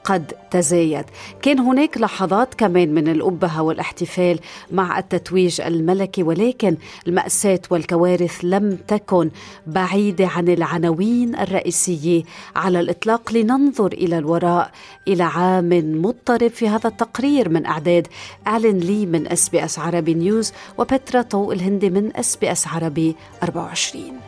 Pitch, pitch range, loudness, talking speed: 185 Hz, 170-210 Hz, -19 LUFS, 125 wpm